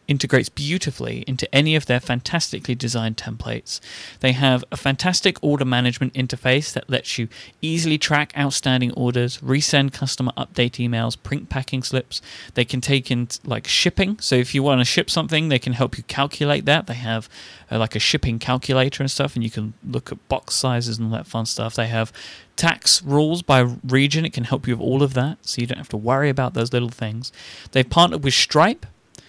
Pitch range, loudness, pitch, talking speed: 120-140 Hz, -20 LUFS, 130 Hz, 200 wpm